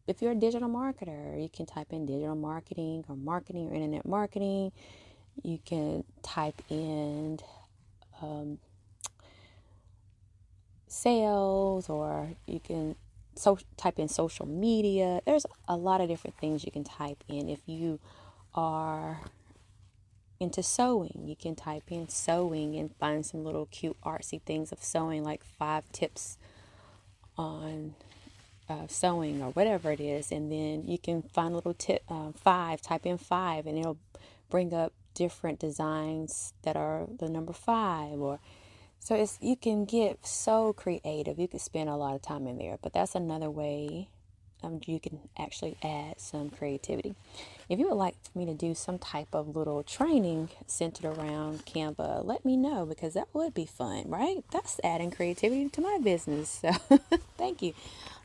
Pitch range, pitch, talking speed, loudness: 140-175 Hz, 155 Hz, 160 wpm, -33 LUFS